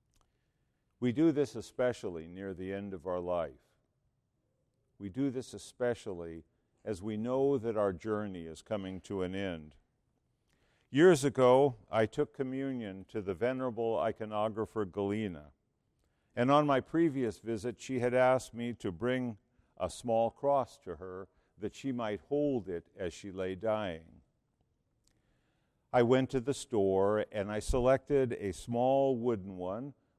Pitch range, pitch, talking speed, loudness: 95-130 Hz, 110 Hz, 145 wpm, -33 LUFS